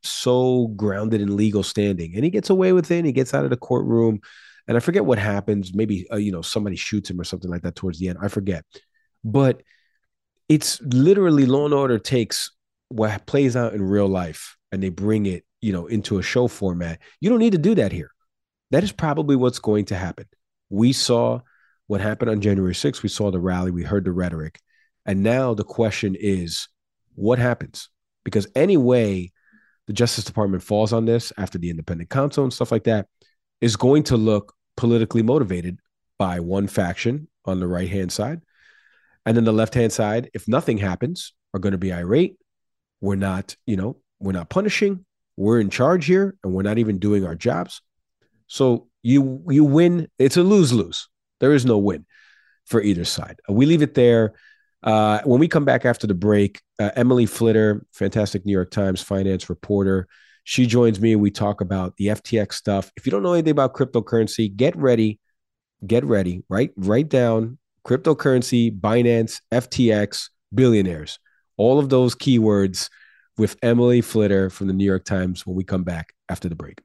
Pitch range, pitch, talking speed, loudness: 95-125 Hz, 110 Hz, 190 wpm, -20 LUFS